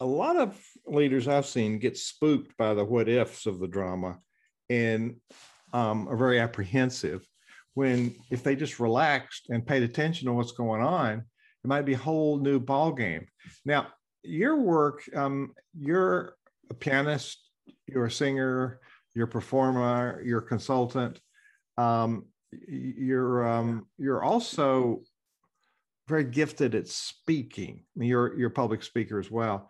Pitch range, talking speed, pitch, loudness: 115-140 Hz, 150 wpm, 125 Hz, -28 LUFS